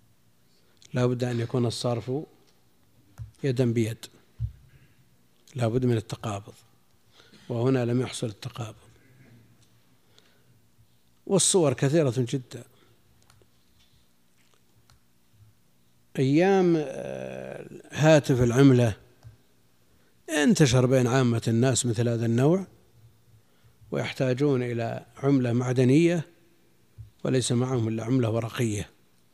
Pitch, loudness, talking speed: 120 Hz, -25 LUFS, 75 wpm